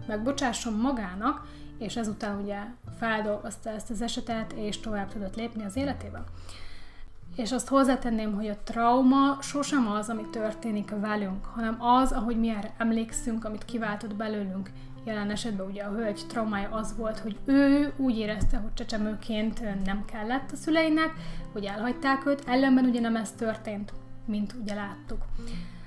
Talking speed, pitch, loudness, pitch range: 150 wpm, 220 Hz, -29 LUFS, 205-240 Hz